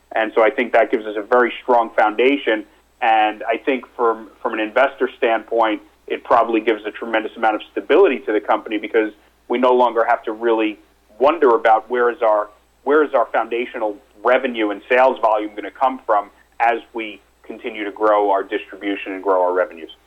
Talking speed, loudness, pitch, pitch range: 195 wpm, -18 LUFS, 110 Hz, 105-120 Hz